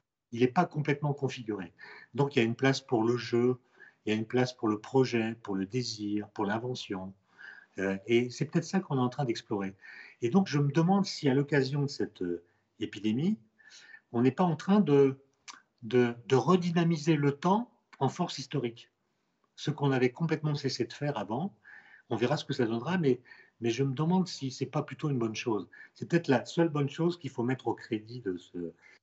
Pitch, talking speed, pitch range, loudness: 130 Hz, 205 wpm, 115-150 Hz, -31 LUFS